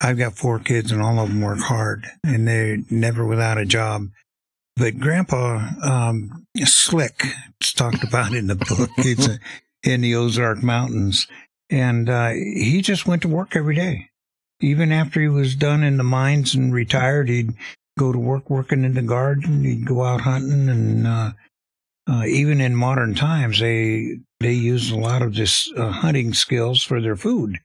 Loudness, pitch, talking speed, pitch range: -19 LUFS, 120 Hz, 180 wpm, 115-135 Hz